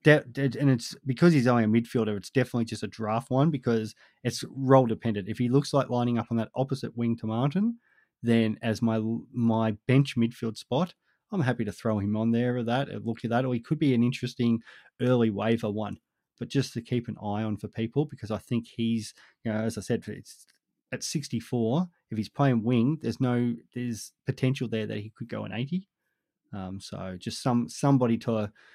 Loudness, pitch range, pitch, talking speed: -28 LUFS, 110-130 Hz, 120 Hz, 210 wpm